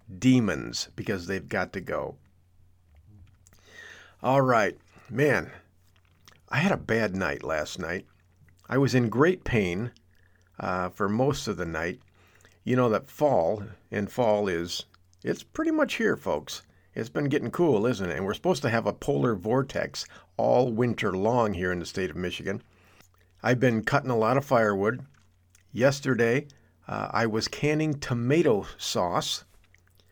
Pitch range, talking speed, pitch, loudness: 90-125 Hz, 150 wpm, 100 Hz, -27 LUFS